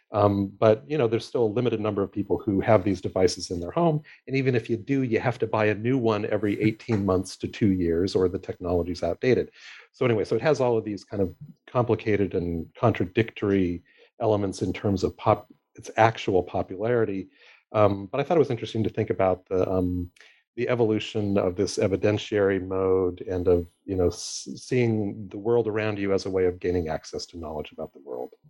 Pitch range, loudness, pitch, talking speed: 95-115 Hz, -25 LUFS, 105 Hz, 210 wpm